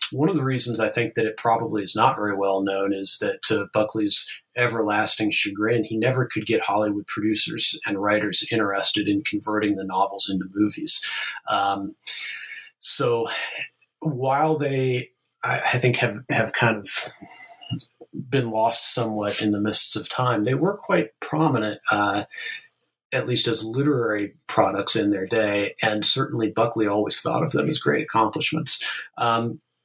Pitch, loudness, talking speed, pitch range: 110 Hz, -21 LUFS, 160 wpm, 105-130 Hz